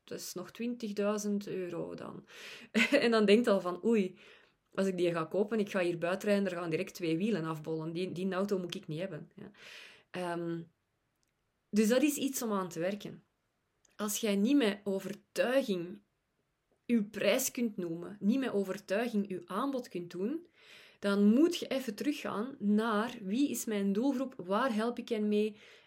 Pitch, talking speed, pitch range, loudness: 205 Hz, 180 wpm, 185-230 Hz, -33 LUFS